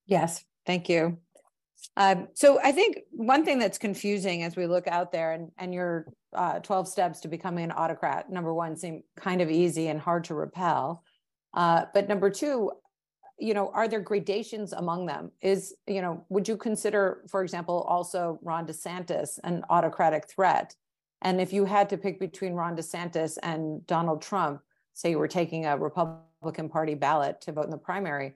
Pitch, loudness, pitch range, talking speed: 175 Hz, -28 LUFS, 165-195 Hz, 180 wpm